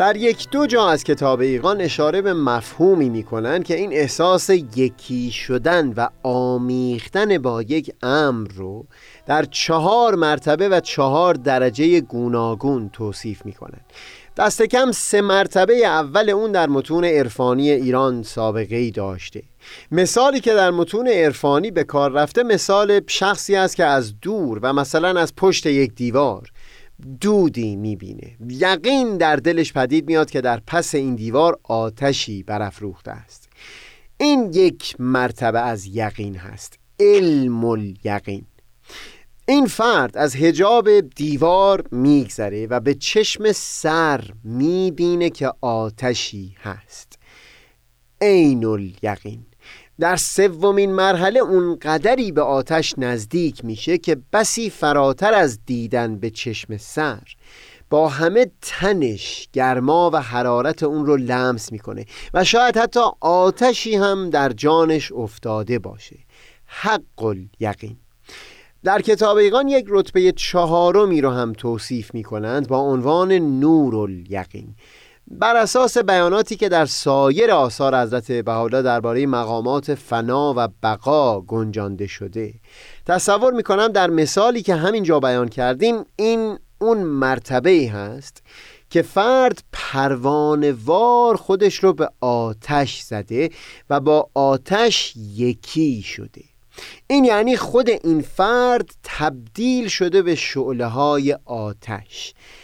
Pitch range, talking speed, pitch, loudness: 120-185 Hz, 120 wpm, 145 Hz, -18 LUFS